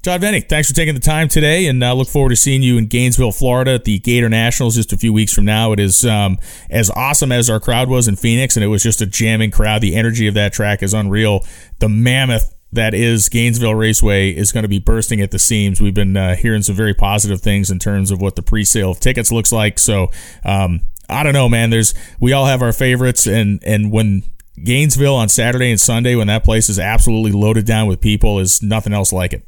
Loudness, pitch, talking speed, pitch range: -14 LUFS, 110 Hz, 245 wpm, 100-120 Hz